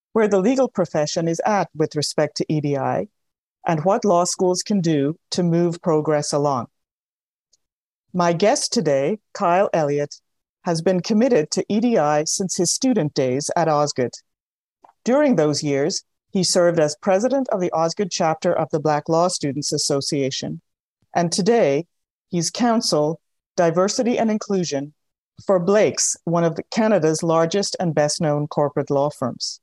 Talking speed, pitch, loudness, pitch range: 145 wpm, 170 Hz, -20 LUFS, 150-195 Hz